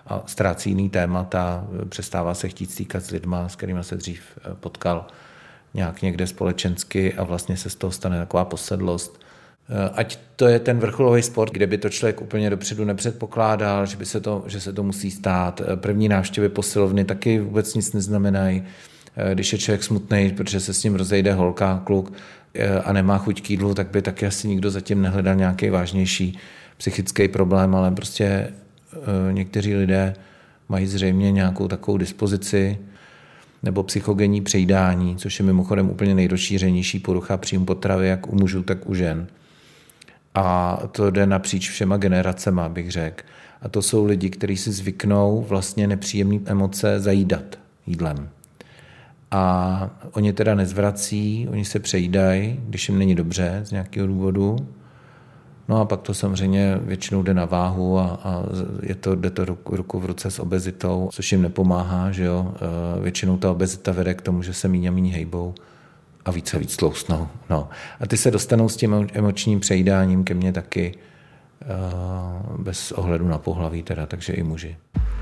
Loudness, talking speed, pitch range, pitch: -22 LUFS, 165 wpm, 90-100 Hz, 95 Hz